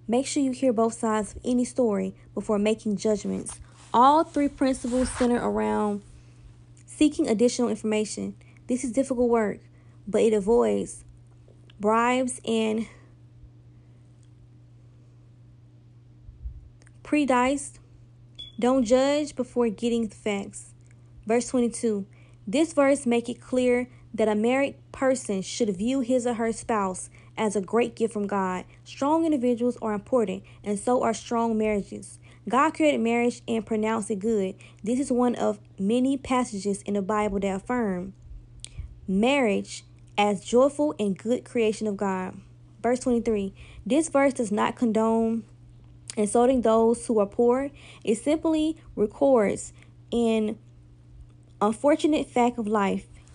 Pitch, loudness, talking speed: 220 Hz, -25 LUFS, 130 wpm